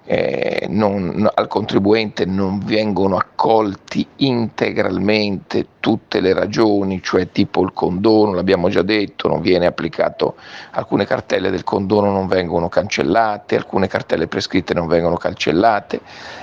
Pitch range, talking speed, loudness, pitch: 95-110 Hz, 120 wpm, -17 LUFS, 100 Hz